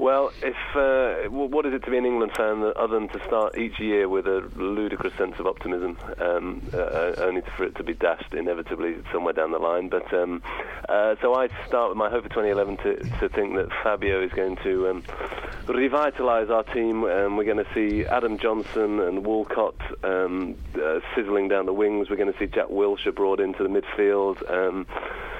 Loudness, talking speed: -25 LUFS, 205 wpm